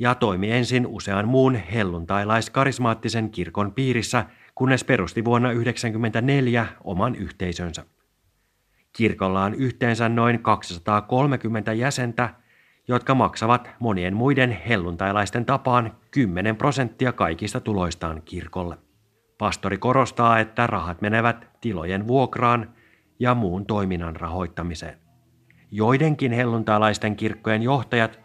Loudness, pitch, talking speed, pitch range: -23 LUFS, 115 Hz, 100 wpm, 100-125 Hz